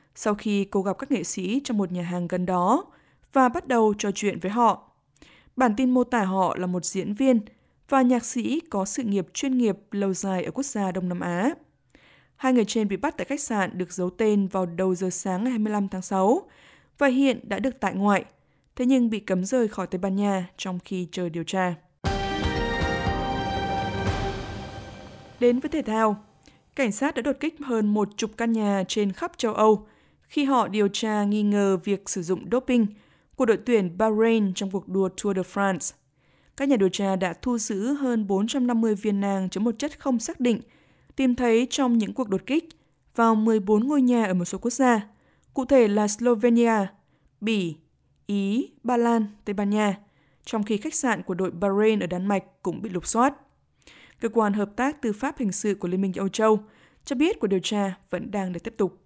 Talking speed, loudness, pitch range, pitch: 205 wpm, -25 LUFS, 190-245 Hz, 210 Hz